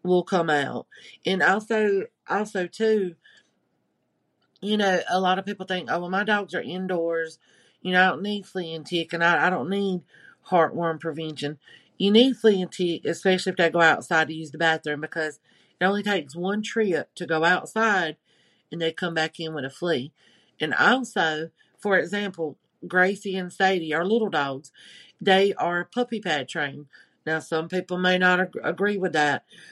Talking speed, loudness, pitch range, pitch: 180 wpm, -24 LUFS, 160-195 Hz, 180 Hz